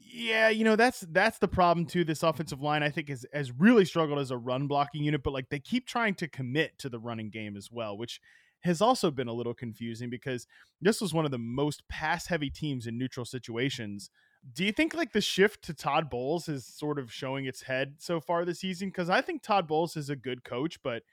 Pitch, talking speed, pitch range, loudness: 150 Hz, 235 wpm, 130-180 Hz, -30 LUFS